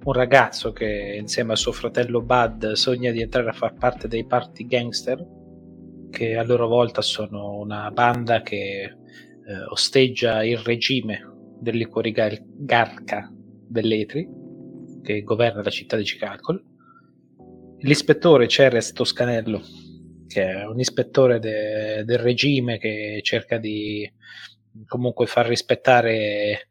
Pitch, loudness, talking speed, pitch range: 115 Hz, -22 LUFS, 120 wpm, 105-120 Hz